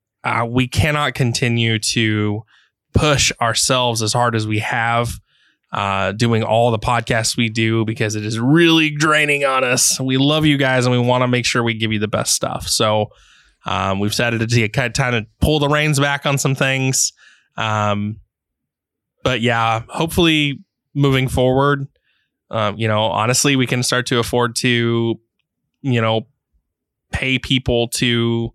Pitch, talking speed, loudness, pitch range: 120 Hz, 165 wpm, -17 LUFS, 110-130 Hz